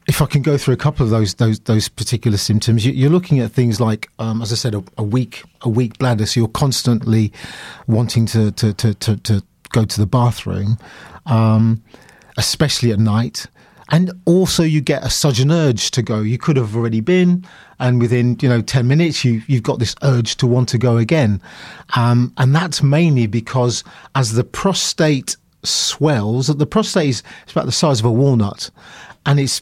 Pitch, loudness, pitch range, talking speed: 125 Hz, -16 LUFS, 115-145 Hz, 195 wpm